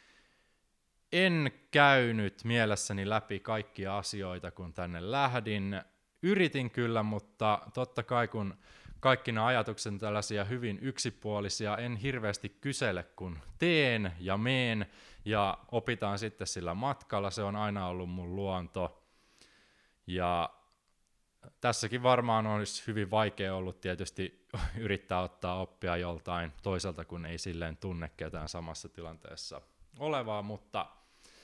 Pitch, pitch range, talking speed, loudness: 105 Hz, 90-120 Hz, 115 wpm, -33 LUFS